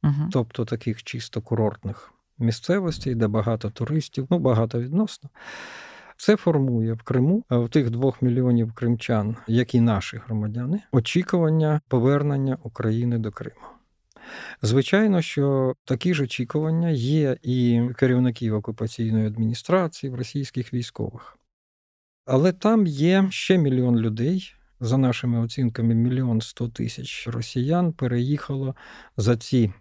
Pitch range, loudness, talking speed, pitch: 115-150 Hz, -23 LUFS, 115 wpm, 125 Hz